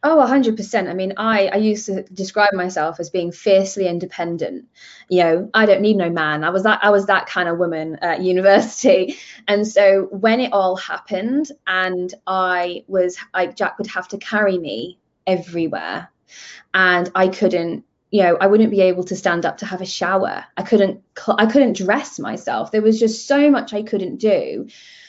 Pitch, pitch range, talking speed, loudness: 195 Hz, 180-210 Hz, 190 wpm, -18 LUFS